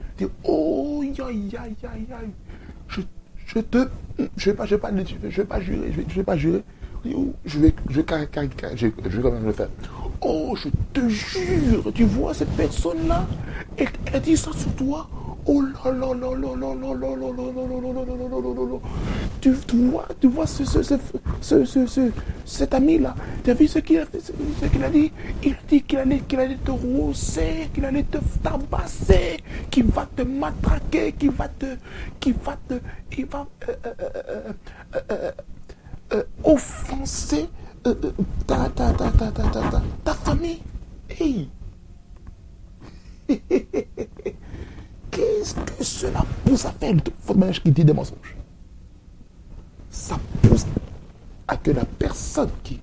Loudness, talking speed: -23 LUFS, 130 wpm